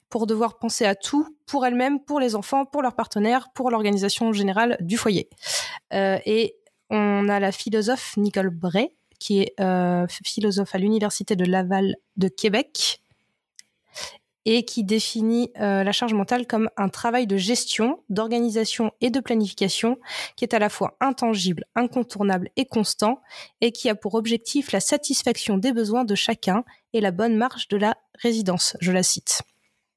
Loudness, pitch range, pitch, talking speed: -23 LUFS, 200-245 Hz, 220 Hz, 165 wpm